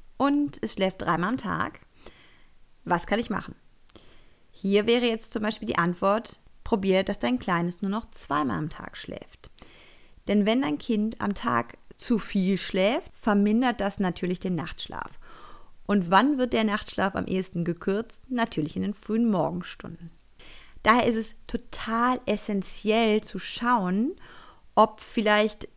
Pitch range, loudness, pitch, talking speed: 190-230 Hz, -26 LUFS, 210 Hz, 145 wpm